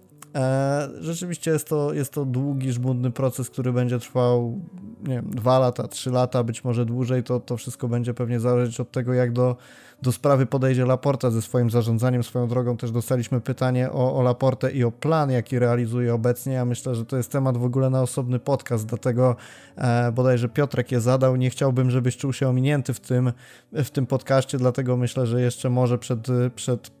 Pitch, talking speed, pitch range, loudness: 125 Hz, 190 wpm, 125-130 Hz, -23 LUFS